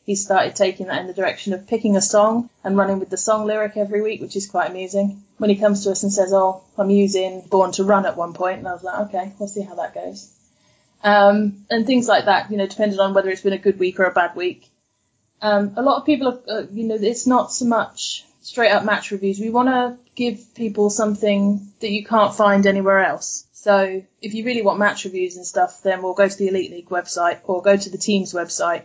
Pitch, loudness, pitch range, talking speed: 200 Hz, -19 LUFS, 190-210 Hz, 250 wpm